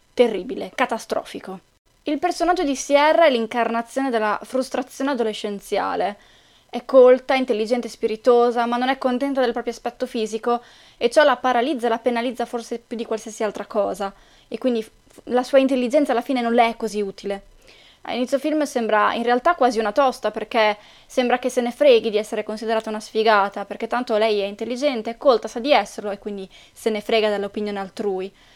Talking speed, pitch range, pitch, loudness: 180 wpm, 215-255 Hz, 235 Hz, -21 LUFS